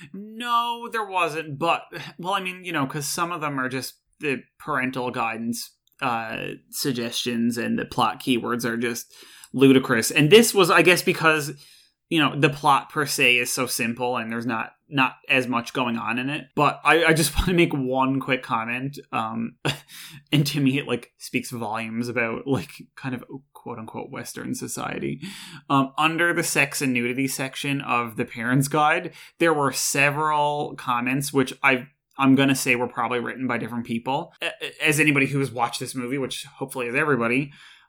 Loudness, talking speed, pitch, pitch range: -23 LUFS, 180 wpm, 135 Hz, 125-150 Hz